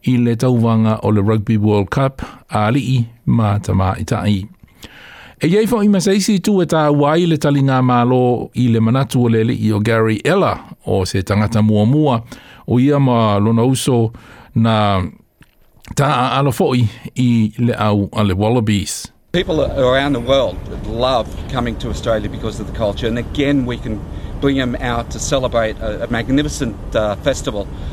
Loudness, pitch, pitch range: -16 LUFS, 115 Hz, 105-130 Hz